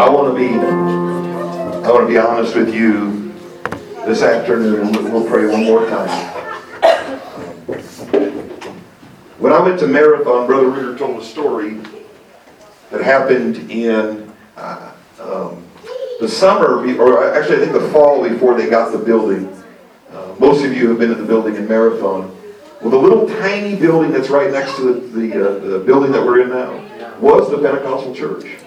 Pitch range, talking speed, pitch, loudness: 110-145 Hz, 175 wpm, 120 Hz, -14 LUFS